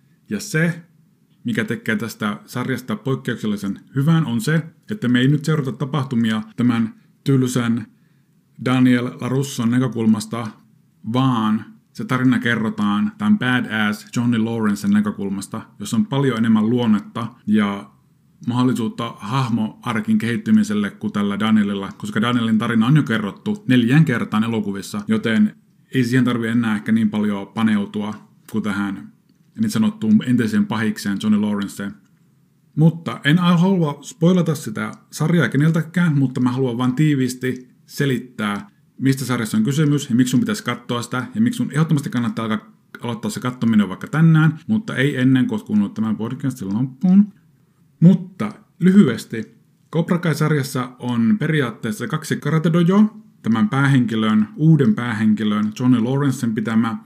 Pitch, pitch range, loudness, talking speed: 125 Hz, 110-160 Hz, -19 LUFS, 135 wpm